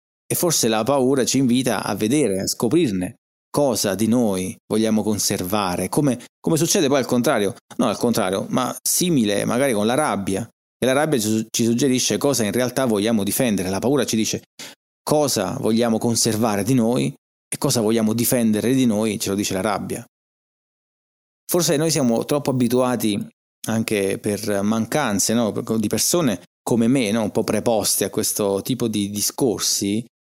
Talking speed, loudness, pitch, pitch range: 160 wpm, -20 LUFS, 110 Hz, 105-125 Hz